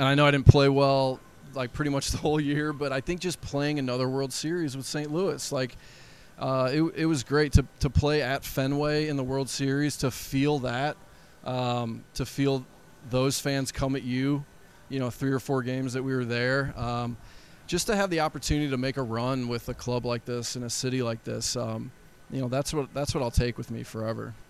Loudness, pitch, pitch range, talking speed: -28 LUFS, 135 Hz, 125-145 Hz, 225 wpm